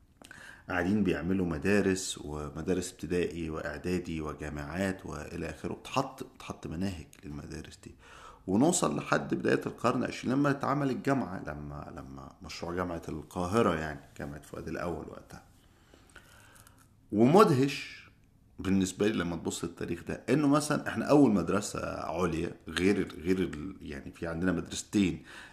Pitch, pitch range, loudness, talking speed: 90 Hz, 80-100 Hz, -31 LUFS, 120 wpm